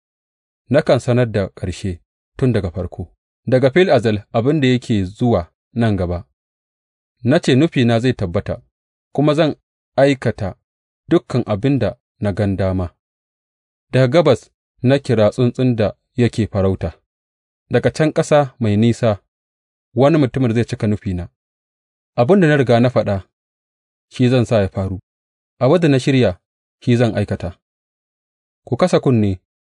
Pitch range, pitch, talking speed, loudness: 90-125 Hz, 110 Hz, 120 wpm, -17 LUFS